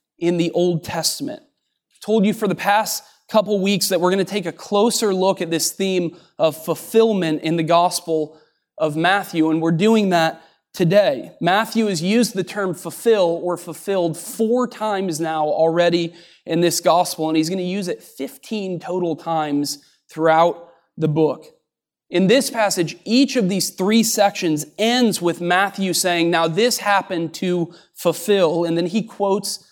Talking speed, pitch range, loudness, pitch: 170 wpm, 165-205 Hz, -19 LUFS, 180 Hz